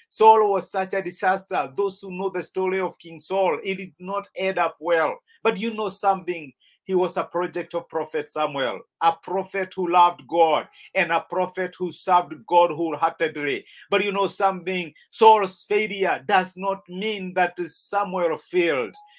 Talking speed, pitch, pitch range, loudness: 170 wpm, 185 Hz, 175-195 Hz, -23 LUFS